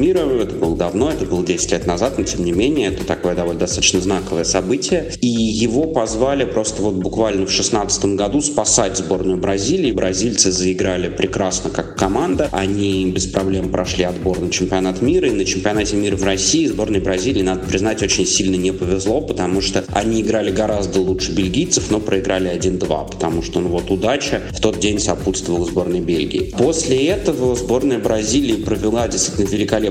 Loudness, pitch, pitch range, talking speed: -17 LUFS, 95 Hz, 95-105 Hz, 175 wpm